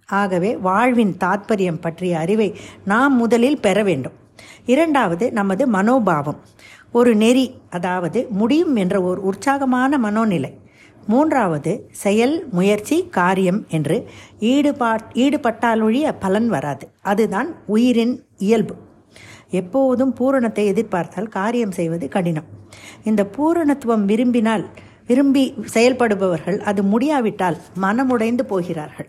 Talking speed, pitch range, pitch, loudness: 95 wpm, 185-245 Hz, 210 Hz, -18 LUFS